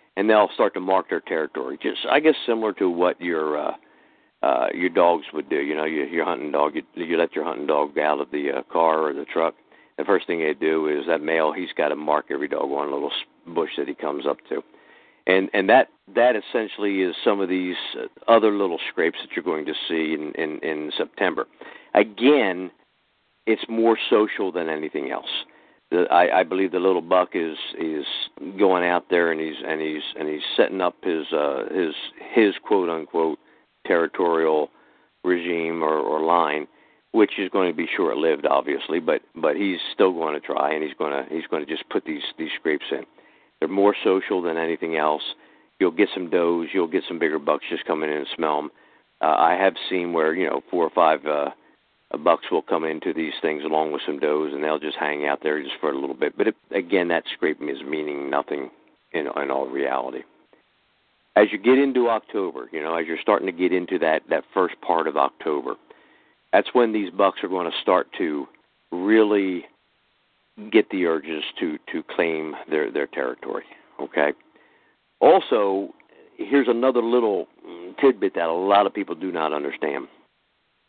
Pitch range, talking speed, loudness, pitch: 75-95 Hz, 195 wpm, -23 LUFS, 85 Hz